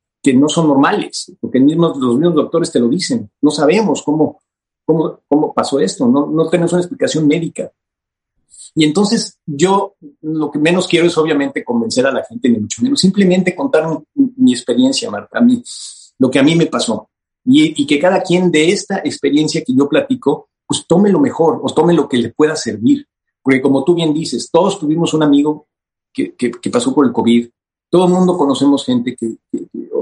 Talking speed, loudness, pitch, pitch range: 200 wpm, -14 LUFS, 160 Hz, 145-190 Hz